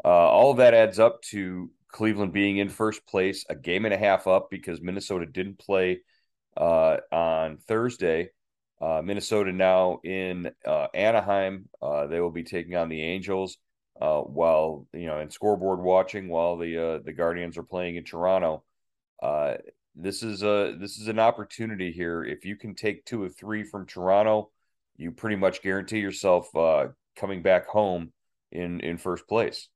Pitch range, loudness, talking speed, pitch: 85-105 Hz, -26 LUFS, 175 wpm, 95 Hz